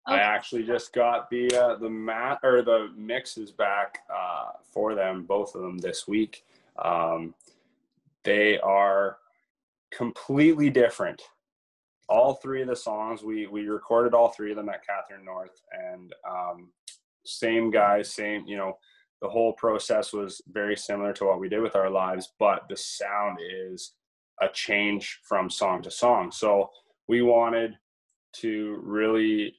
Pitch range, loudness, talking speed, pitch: 100-115 Hz, -26 LUFS, 150 wpm, 105 Hz